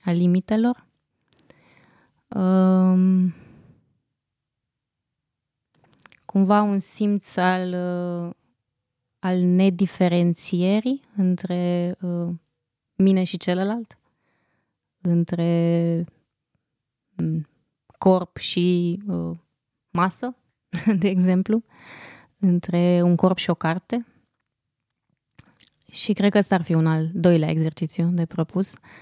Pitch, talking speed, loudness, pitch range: 175 Hz, 85 wpm, -22 LUFS, 150-185 Hz